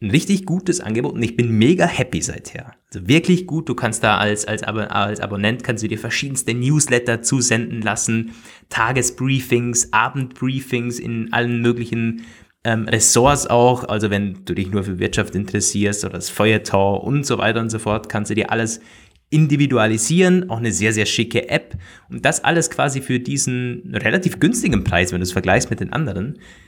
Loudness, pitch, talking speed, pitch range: -18 LUFS, 115 Hz, 180 wpm, 105-125 Hz